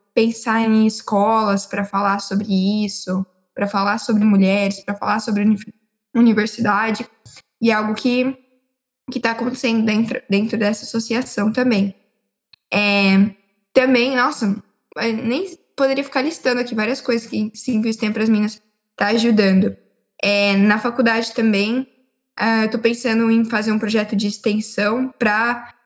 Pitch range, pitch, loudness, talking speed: 205-240 Hz, 220 Hz, -18 LUFS, 135 wpm